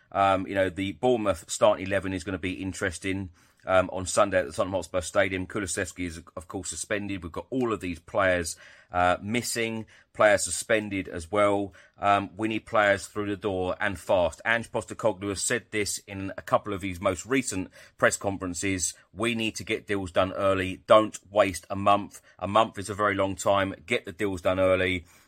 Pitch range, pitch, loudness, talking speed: 95-105 Hz, 100 Hz, -27 LUFS, 195 wpm